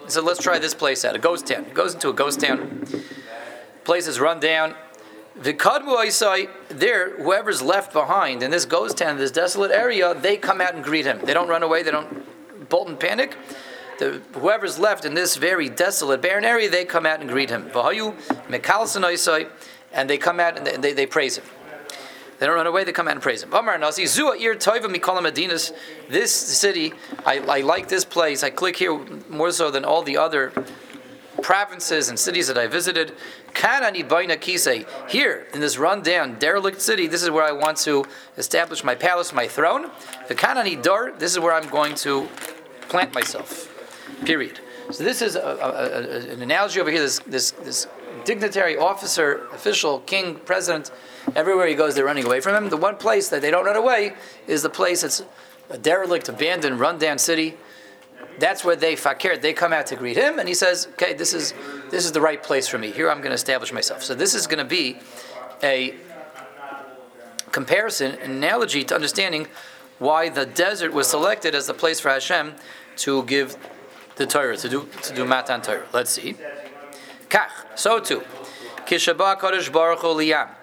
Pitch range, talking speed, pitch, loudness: 140-180 Hz, 185 wpm, 165 Hz, -21 LUFS